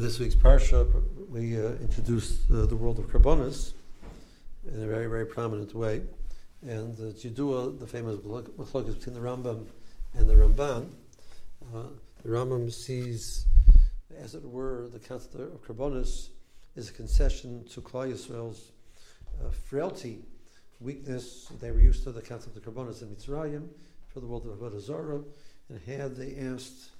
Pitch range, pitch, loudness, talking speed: 110-130 Hz, 120 Hz, -31 LUFS, 150 wpm